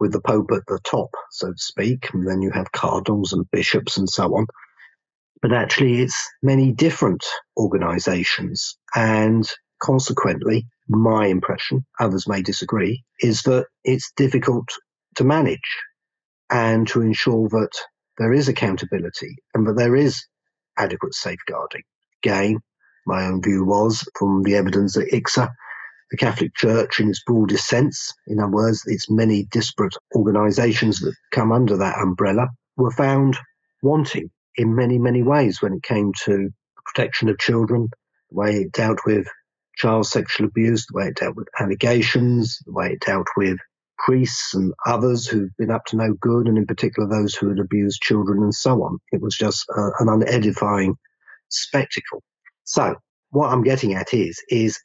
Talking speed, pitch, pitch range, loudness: 160 wpm, 110 Hz, 100-125 Hz, -20 LUFS